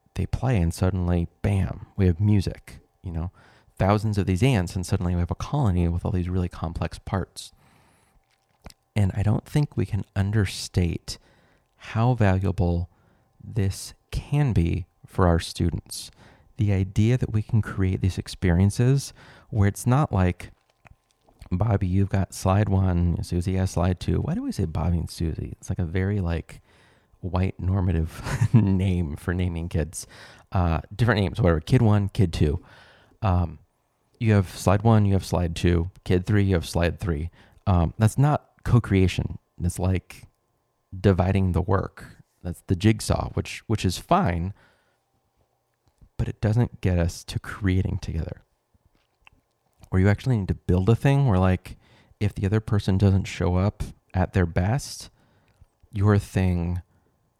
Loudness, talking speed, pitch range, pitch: -24 LUFS, 155 wpm, 90-110 Hz, 95 Hz